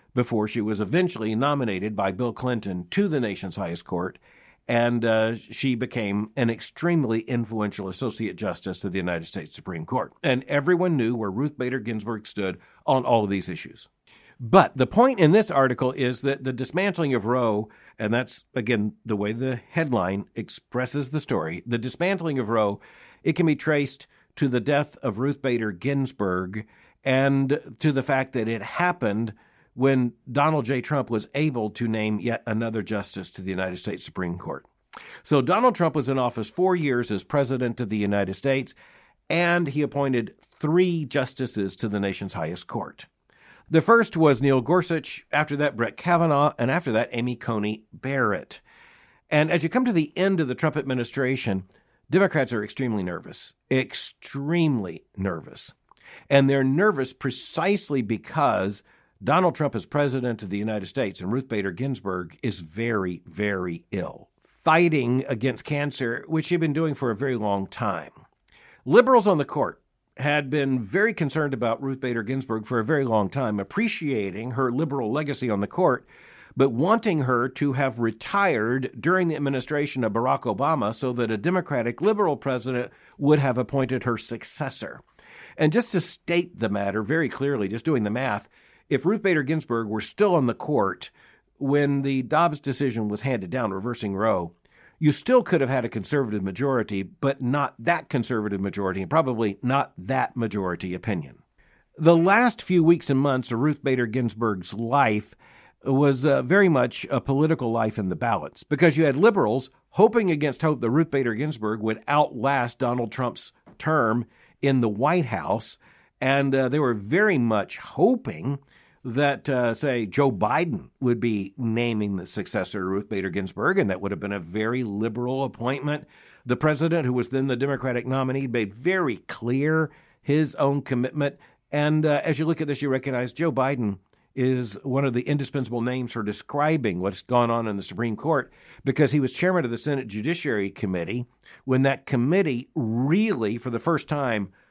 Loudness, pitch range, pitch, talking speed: -24 LUFS, 110-145 Hz, 130 Hz, 170 wpm